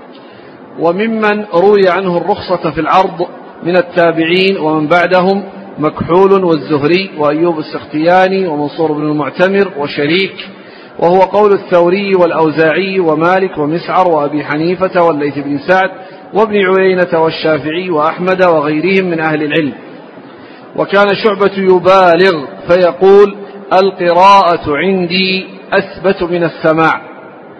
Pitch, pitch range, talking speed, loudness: 180 Hz, 160-190 Hz, 100 wpm, -11 LUFS